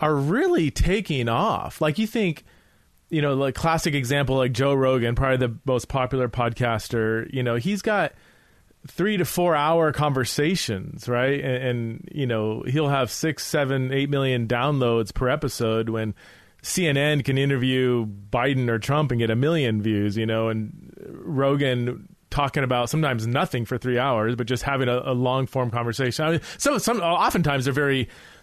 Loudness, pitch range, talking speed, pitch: -23 LUFS, 120-150 Hz, 170 wpm, 130 Hz